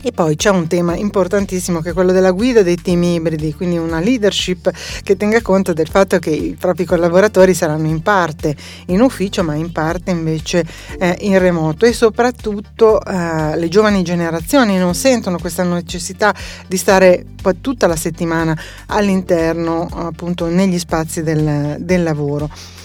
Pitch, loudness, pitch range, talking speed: 180 Hz, -15 LUFS, 165-195 Hz, 160 wpm